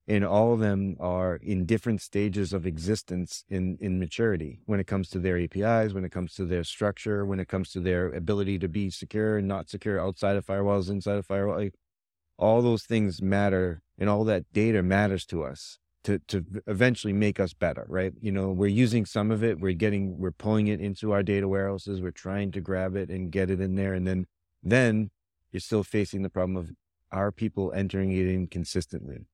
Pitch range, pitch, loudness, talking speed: 90-105 Hz, 95 Hz, -28 LUFS, 210 wpm